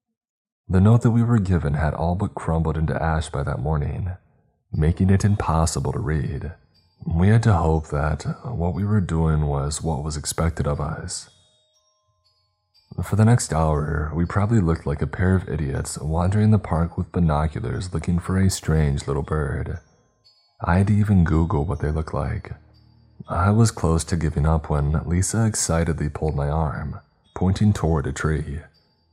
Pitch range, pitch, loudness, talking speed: 75-100 Hz, 85 Hz, -22 LUFS, 165 wpm